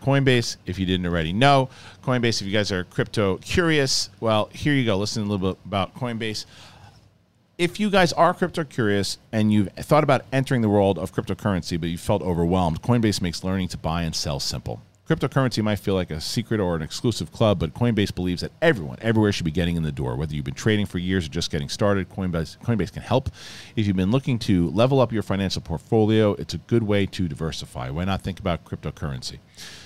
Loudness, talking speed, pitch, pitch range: -23 LUFS, 215 wpm, 100 Hz, 90-120 Hz